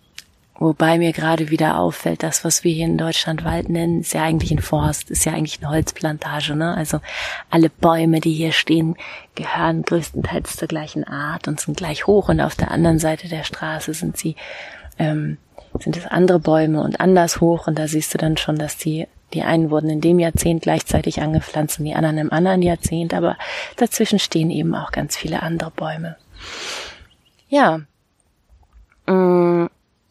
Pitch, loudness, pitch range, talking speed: 160 Hz, -19 LUFS, 155-170 Hz, 175 wpm